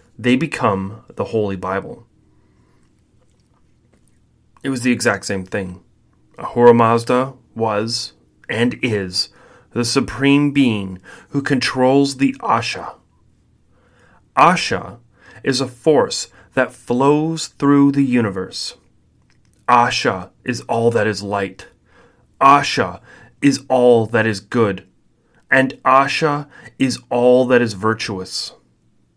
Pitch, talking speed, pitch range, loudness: 120 Hz, 105 wpm, 100-130 Hz, -17 LUFS